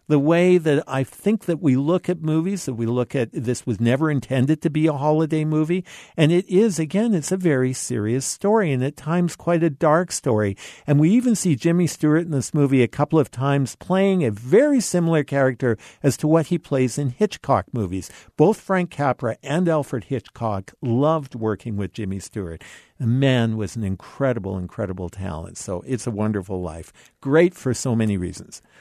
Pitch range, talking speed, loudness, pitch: 115-165 Hz, 195 wpm, -21 LUFS, 140 Hz